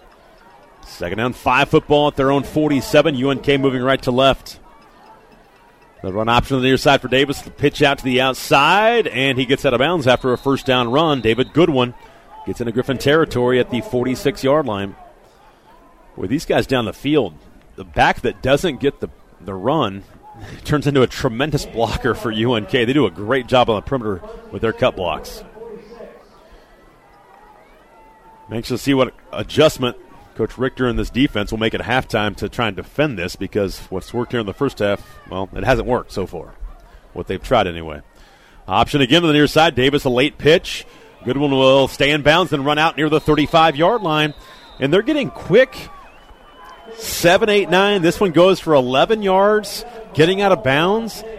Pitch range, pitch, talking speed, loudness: 120-155 Hz, 135 Hz, 190 wpm, -17 LUFS